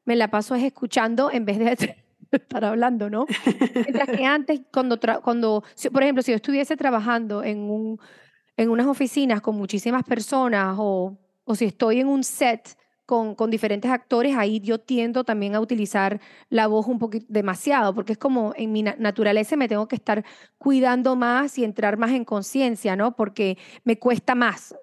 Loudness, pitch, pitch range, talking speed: -23 LUFS, 230 Hz, 215-255 Hz, 180 wpm